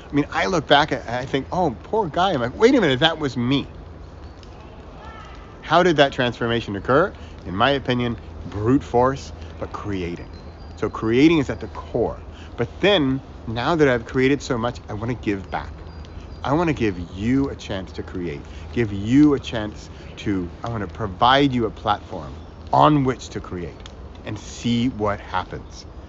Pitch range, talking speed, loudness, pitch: 85-125 Hz, 180 wpm, -21 LUFS, 105 Hz